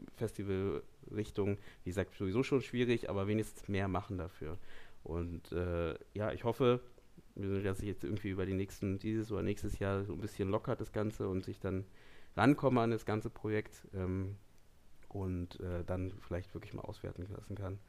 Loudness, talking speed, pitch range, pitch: -38 LUFS, 170 wpm, 95-110 Hz, 100 Hz